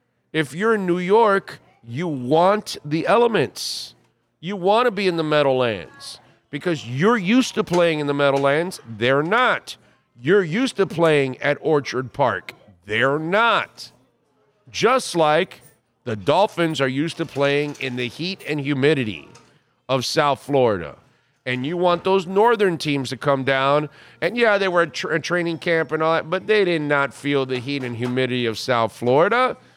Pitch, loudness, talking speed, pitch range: 150 Hz, -20 LUFS, 165 wpm, 130-180 Hz